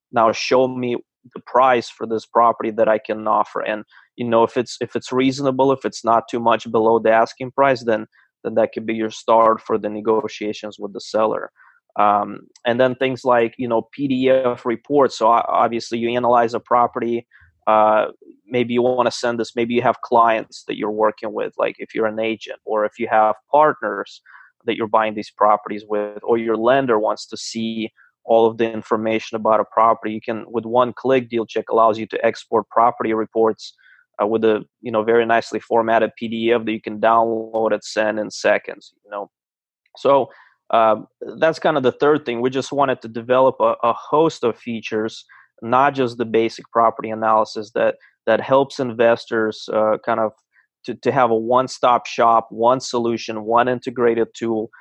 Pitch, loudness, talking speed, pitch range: 115 Hz, -19 LUFS, 190 wpm, 110-120 Hz